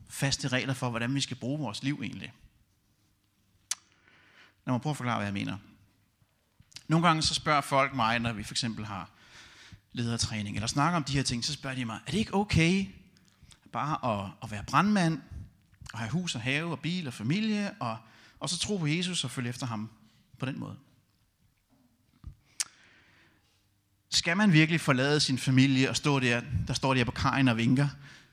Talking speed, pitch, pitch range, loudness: 185 wpm, 125 Hz, 105-145 Hz, -29 LUFS